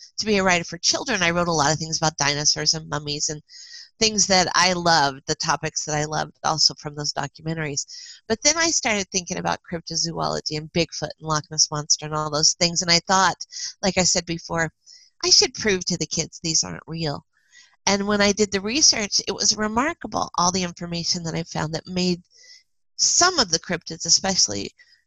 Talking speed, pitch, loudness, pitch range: 205 wpm, 175 Hz, -21 LUFS, 155-215 Hz